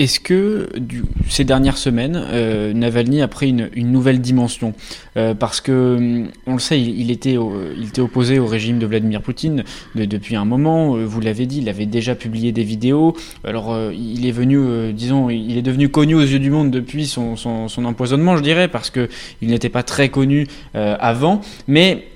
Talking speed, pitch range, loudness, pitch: 205 wpm, 115-140 Hz, -17 LUFS, 125 Hz